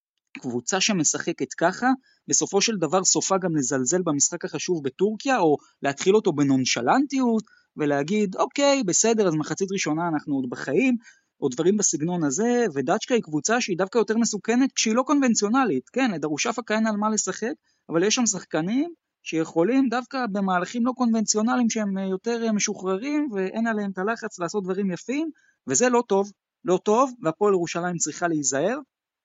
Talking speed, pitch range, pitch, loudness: 150 wpm, 170-240 Hz, 205 Hz, -23 LUFS